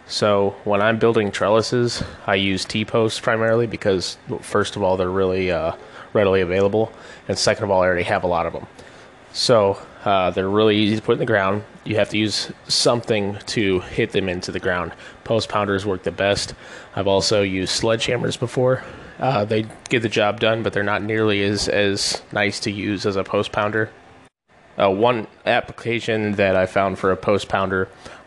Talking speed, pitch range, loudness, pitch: 190 wpm, 95-110 Hz, -20 LUFS, 100 Hz